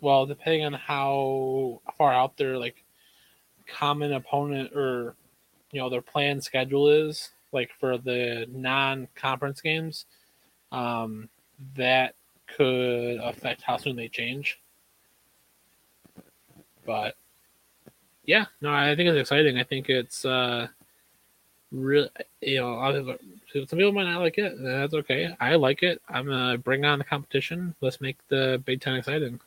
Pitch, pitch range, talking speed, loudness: 135 Hz, 125-145 Hz, 140 wpm, -26 LUFS